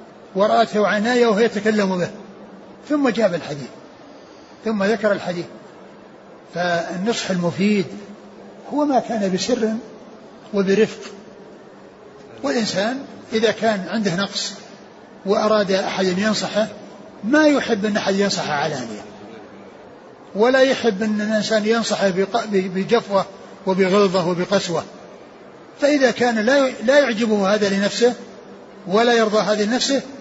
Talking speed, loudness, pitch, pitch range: 100 wpm, -19 LUFS, 215 Hz, 200-230 Hz